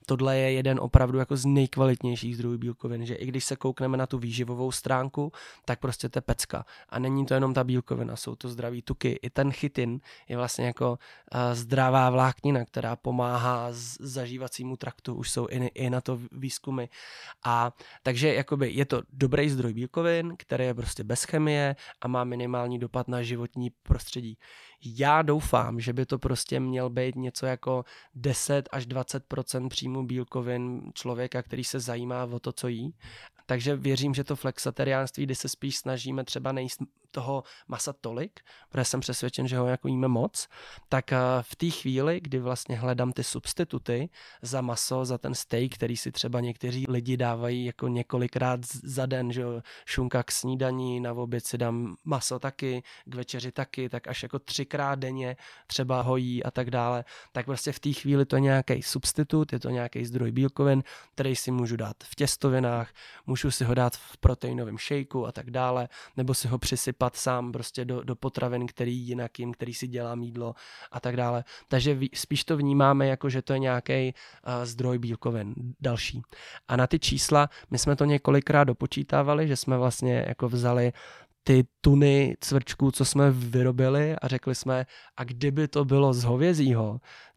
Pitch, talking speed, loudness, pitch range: 130 Hz, 175 wpm, -28 LUFS, 125-135 Hz